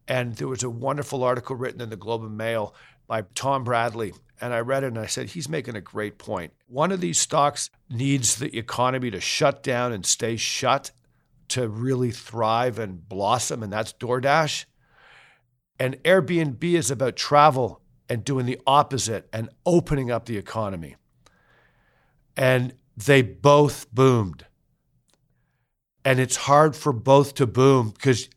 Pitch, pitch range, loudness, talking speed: 125 Hz, 115-140 Hz, -23 LUFS, 155 wpm